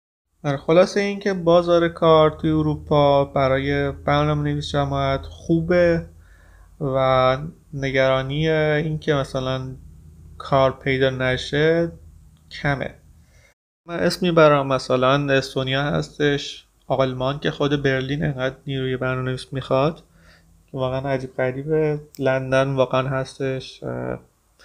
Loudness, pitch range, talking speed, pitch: -21 LUFS, 130-150 Hz, 100 wpm, 135 Hz